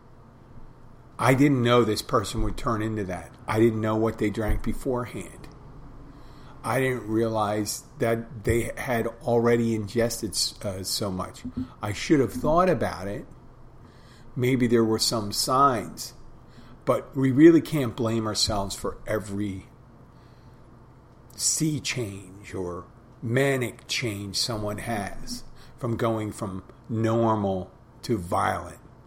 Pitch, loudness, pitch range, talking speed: 115 Hz, -25 LUFS, 110-125 Hz, 120 wpm